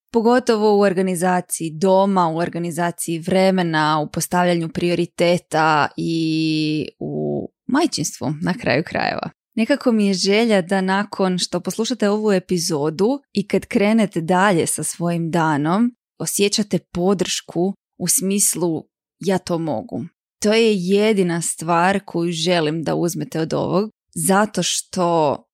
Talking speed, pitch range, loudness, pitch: 120 wpm, 165-200 Hz, -19 LUFS, 180 Hz